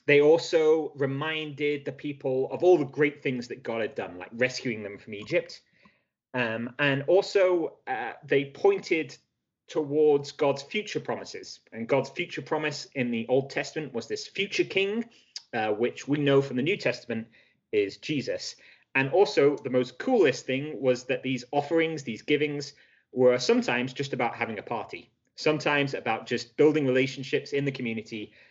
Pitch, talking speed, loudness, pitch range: 145 Hz, 165 wpm, -27 LUFS, 125-175 Hz